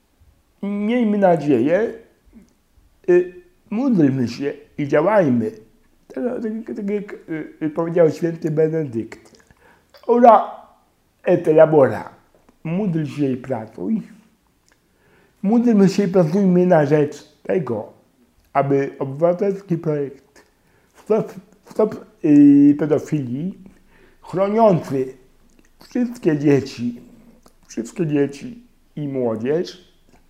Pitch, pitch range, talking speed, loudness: 175 Hz, 145-220 Hz, 85 wpm, -19 LUFS